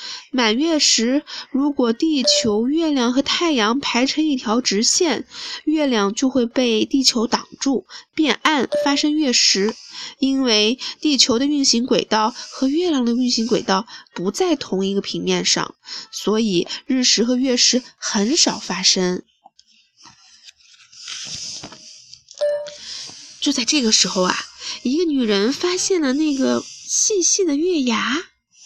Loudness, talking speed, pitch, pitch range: -18 LUFS, 190 characters per minute, 260 Hz, 225-300 Hz